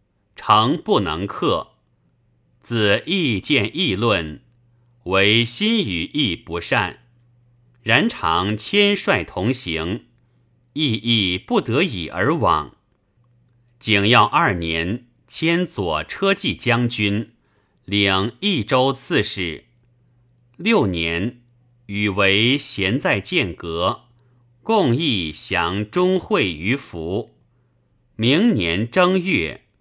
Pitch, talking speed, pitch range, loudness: 120 Hz, 125 characters per minute, 100-125 Hz, -19 LUFS